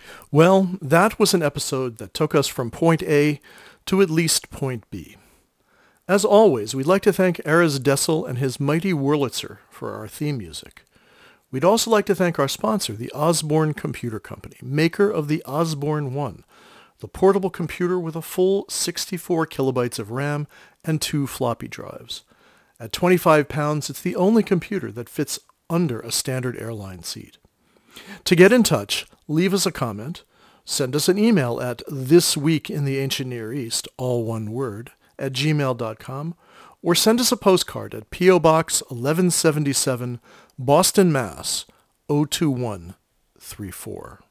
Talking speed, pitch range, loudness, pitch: 150 wpm, 130-180 Hz, -21 LUFS, 150 Hz